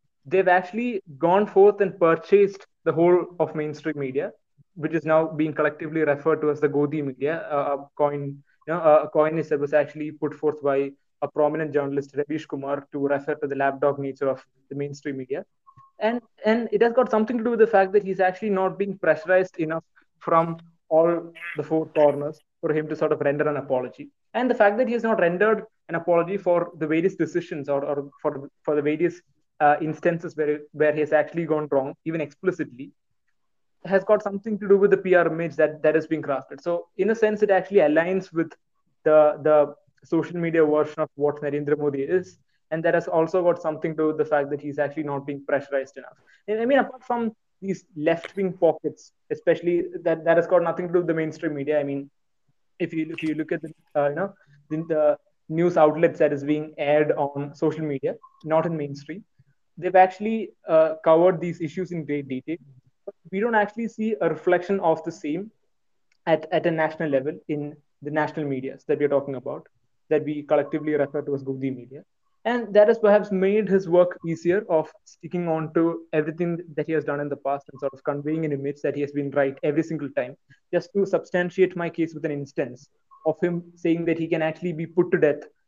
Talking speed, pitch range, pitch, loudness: 215 wpm, 145-180 Hz, 160 Hz, -24 LUFS